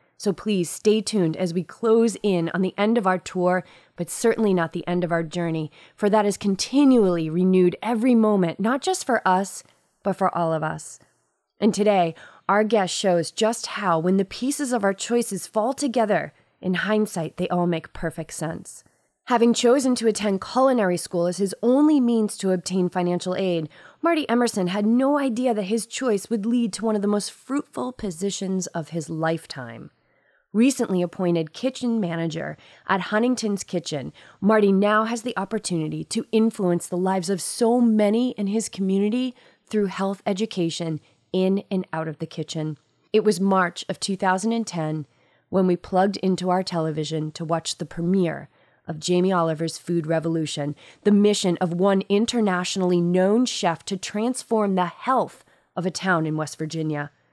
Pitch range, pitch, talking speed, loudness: 170-220 Hz, 190 Hz, 170 wpm, -23 LUFS